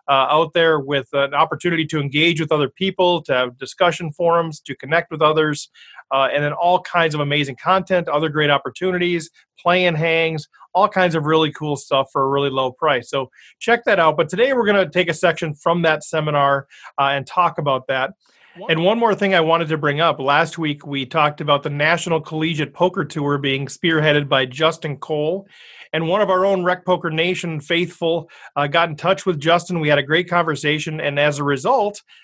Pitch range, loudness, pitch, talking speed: 145-175 Hz, -18 LUFS, 160 Hz, 210 wpm